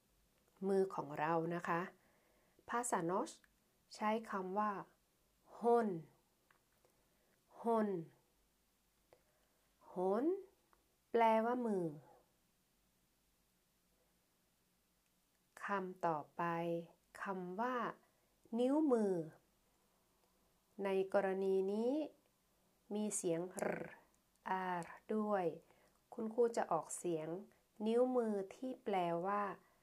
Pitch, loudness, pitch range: 195 Hz, -40 LUFS, 170-220 Hz